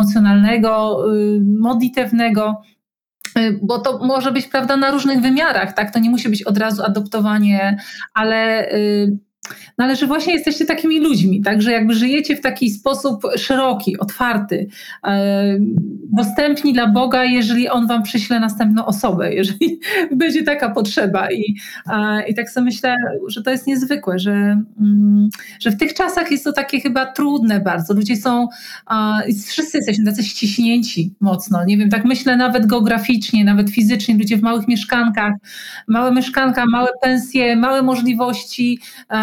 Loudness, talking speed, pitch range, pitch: -16 LUFS, 155 wpm, 210-260 Hz, 230 Hz